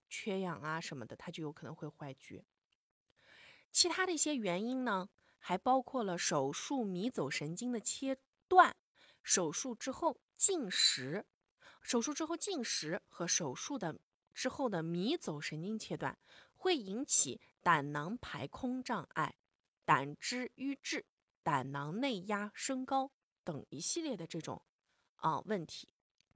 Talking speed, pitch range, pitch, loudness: 205 characters per minute, 165-270 Hz, 225 Hz, -35 LUFS